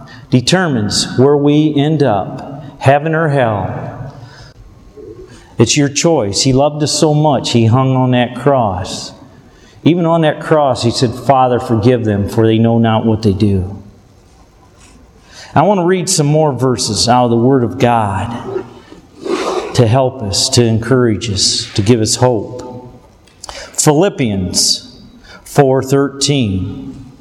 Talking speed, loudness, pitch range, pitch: 135 wpm, -12 LUFS, 110-140 Hz, 125 Hz